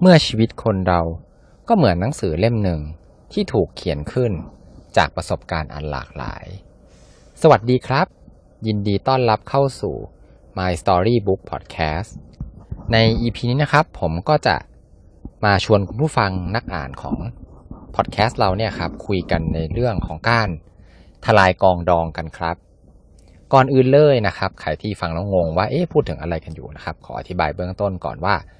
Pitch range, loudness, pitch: 85-115 Hz, -19 LUFS, 95 Hz